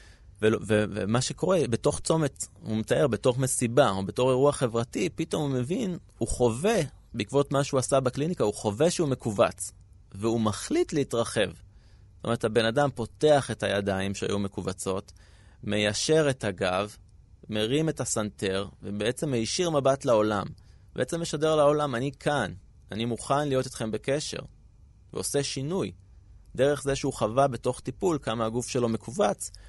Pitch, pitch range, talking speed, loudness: 120 Hz, 105-140 Hz, 145 wpm, -27 LUFS